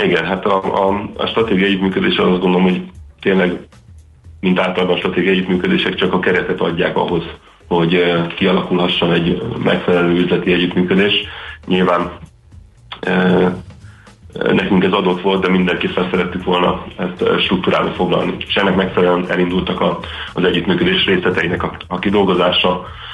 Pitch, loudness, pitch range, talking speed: 90 Hz, -15 LUFS, 90-95 Hz, 135 wpm